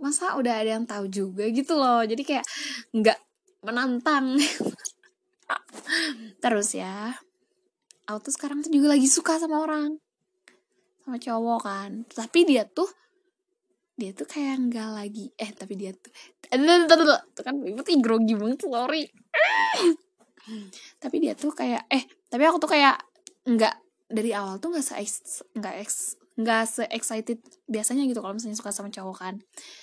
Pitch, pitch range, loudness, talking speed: 260 Hz, 220-320 Hz, -25 LUFS, 140 wpm